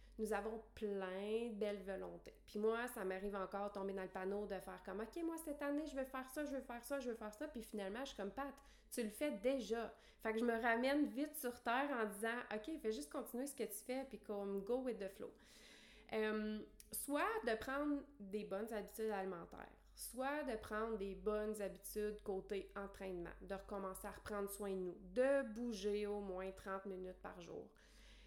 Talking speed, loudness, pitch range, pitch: 210 wpm, -45 LUFS, 200-250 Hz, 215 Hz